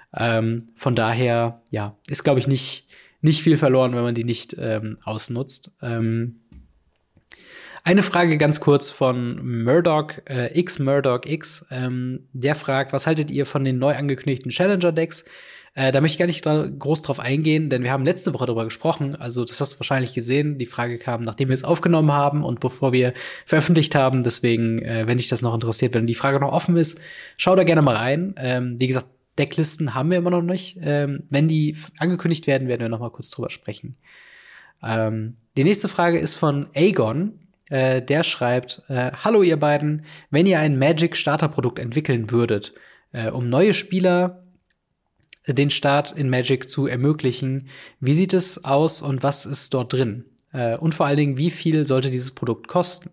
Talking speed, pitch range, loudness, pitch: 180 wpm, 125-160 Hz, -20 LUFS, 140 Hz